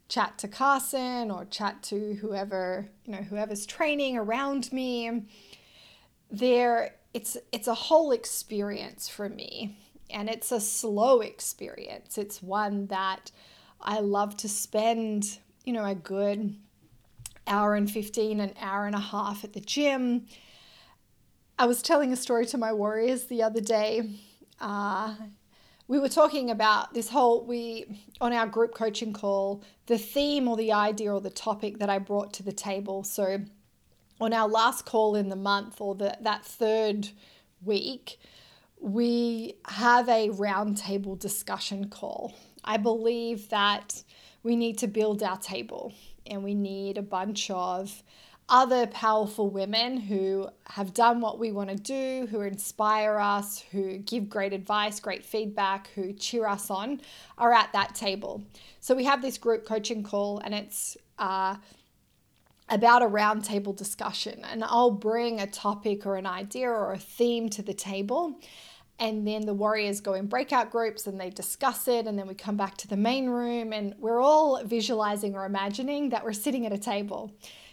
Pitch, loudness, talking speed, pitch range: 215 Hz, -28 LUFS, 160 wpm, 200-235 Hz